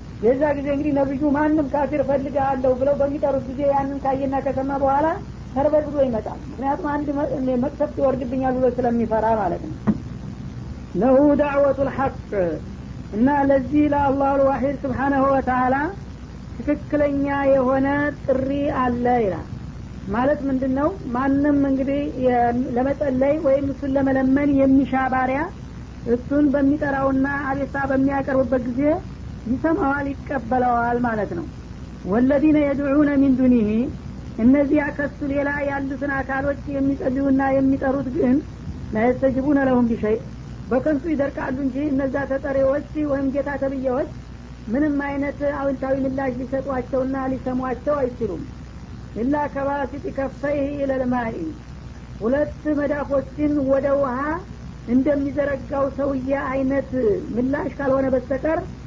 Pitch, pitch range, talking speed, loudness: 275 Hz, 265-285 Hz, 105 wpm, -21 LUFS